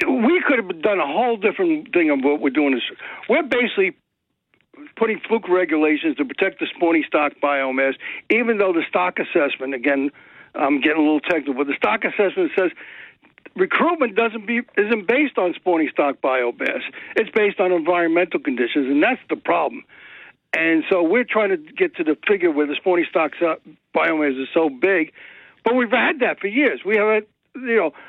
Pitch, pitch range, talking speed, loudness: 185 Hz, 150-240 Hz, 180 wpm, -20 LUFS